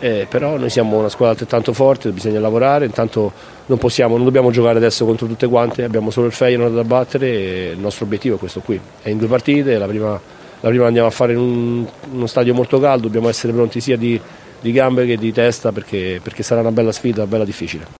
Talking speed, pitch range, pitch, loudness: 235 wpm, 110-125 Hz, 115 Hz, -16 LUFS